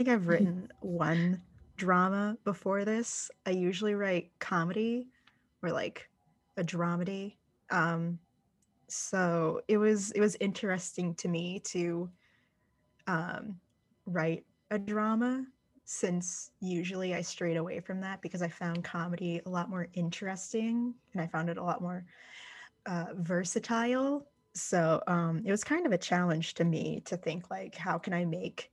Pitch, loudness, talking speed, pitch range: 180 Hz, -33 LUFS, 145 wpm, 170-210 Hz